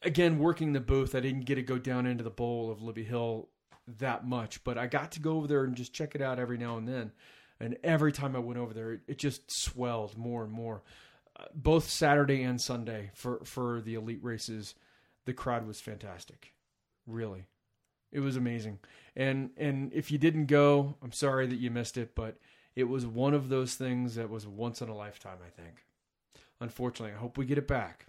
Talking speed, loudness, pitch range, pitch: 210 wpm, -33 LUFS, 115-135 Hz, 125 Hz